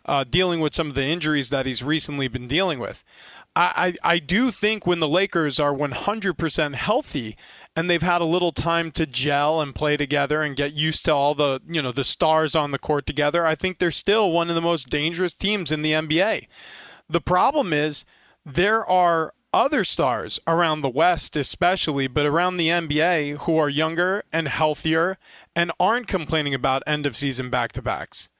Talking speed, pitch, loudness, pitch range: 195 wpm, 160 Hz, -22 LUFS, 145-175 Hz